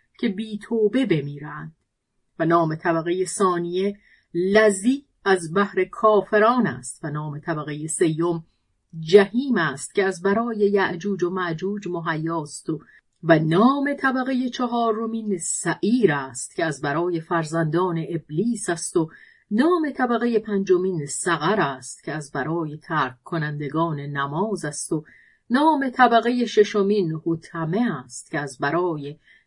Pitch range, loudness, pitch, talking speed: 160-210 Hz, -22 LUFS, 175 Hz, 125 wpm